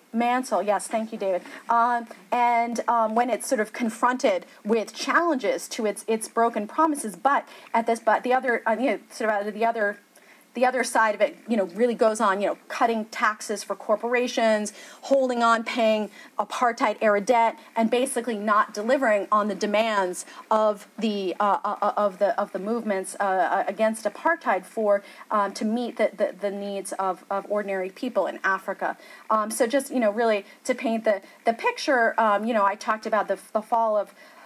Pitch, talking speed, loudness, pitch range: 225 Hz, 190 wpm, -24 LUFS, 205-245 Hz